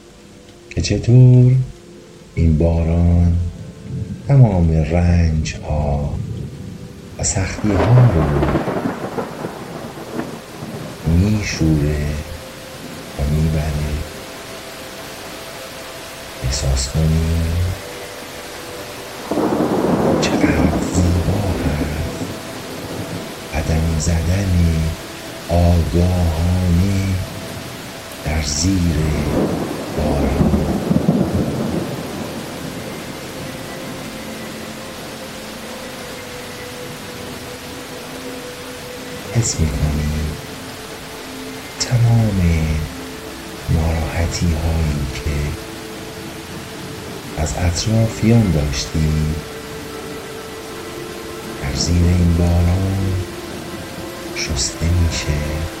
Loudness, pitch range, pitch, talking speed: -19 LUFS, 80-95 Hz, 85 Hz, 40 wpm